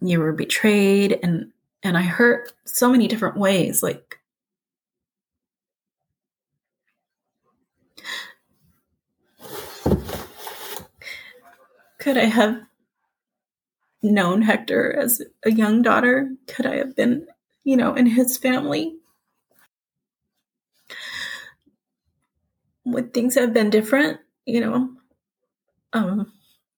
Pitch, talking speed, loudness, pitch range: 245 Hz, 85 wpm, -20 LUFS, 215-265 Hz